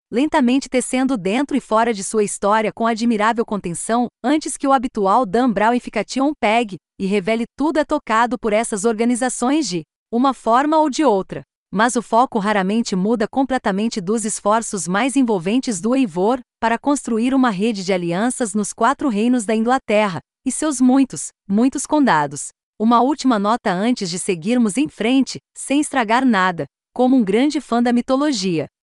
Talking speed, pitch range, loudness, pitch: 165 wpm, 210-260 Hz, -18 LUFS, 235 Hz